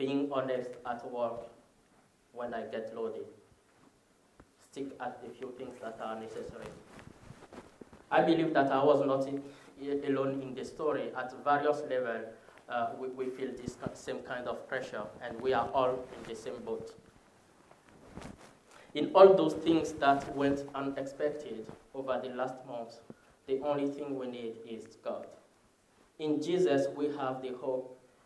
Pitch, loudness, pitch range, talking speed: 130 Hz, -33 LUFS, 125-140 Hz, 155 wpm